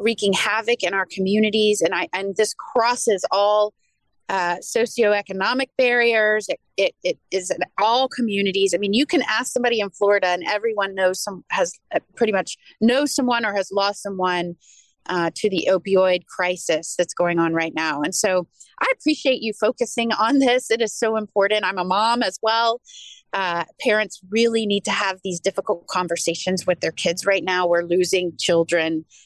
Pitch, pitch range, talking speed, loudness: 200 Hz, 180-230 Hz, 180 wpm, -21 LUFS